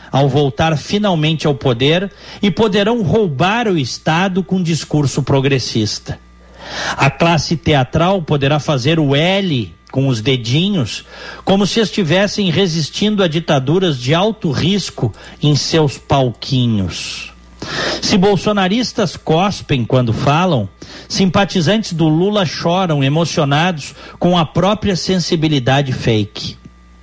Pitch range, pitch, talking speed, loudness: 135-190 Hz, 160 Hz, 110 wpm, -15 LUFS